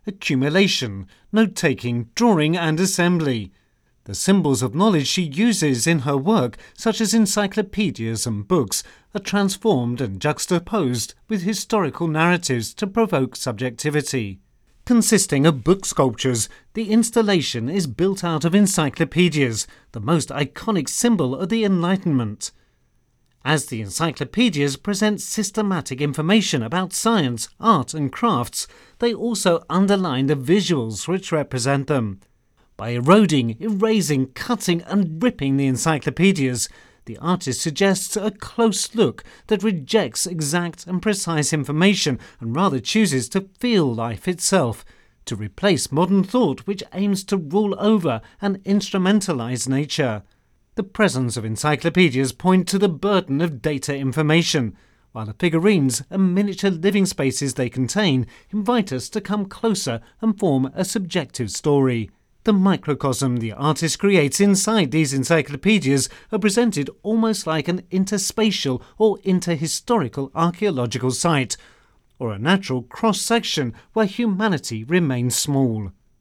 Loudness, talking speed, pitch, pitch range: -20 LUFS, 130 wpm, 170 Hz, 130-200 Hz